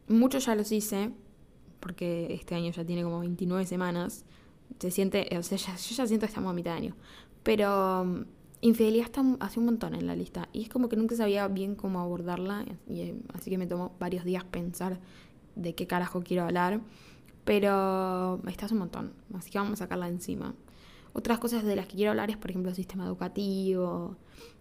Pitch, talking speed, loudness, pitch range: 190 Hz, 195 wpm, -31 LUFS, 180-215 Hz